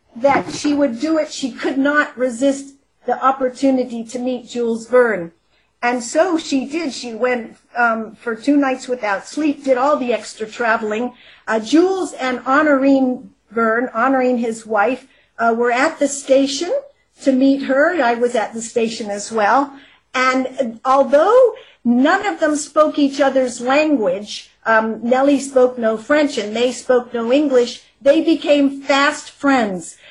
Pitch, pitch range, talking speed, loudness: 260 Hz, 235-285 Hz, 160 wpm, -17 LUFS